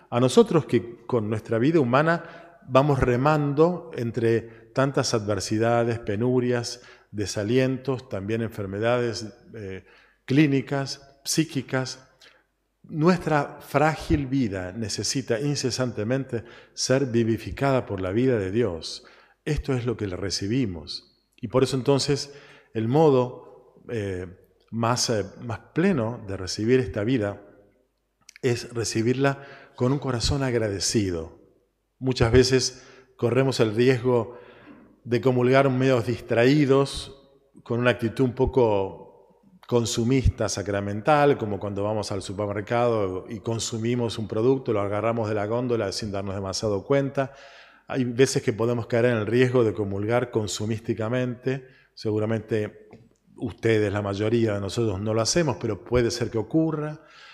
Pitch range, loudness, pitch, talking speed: 110-135 Hz, -24 LUFS, 120 Hz, 120 wpm